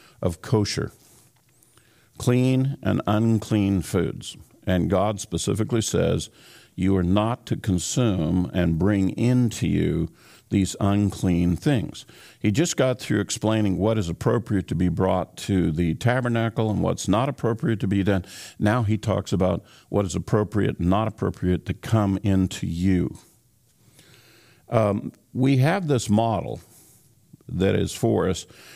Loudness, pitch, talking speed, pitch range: -23 LUFS, 105 Hz, 140 wpm, 95-115 Hz